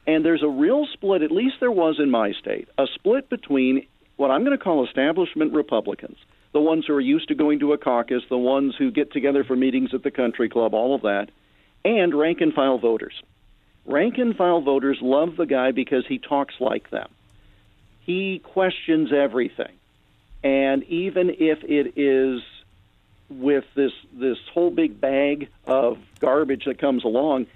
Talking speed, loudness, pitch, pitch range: 180 wpm, -22 LUFS, 140 Hz, 130-160 Hz